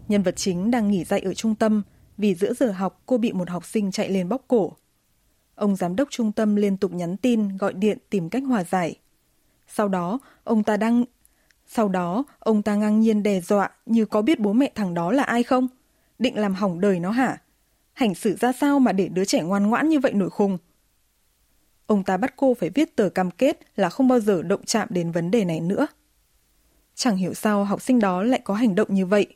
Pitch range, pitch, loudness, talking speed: 190-245 Hz, 210 Hz, -23 LUFS, 230 wpm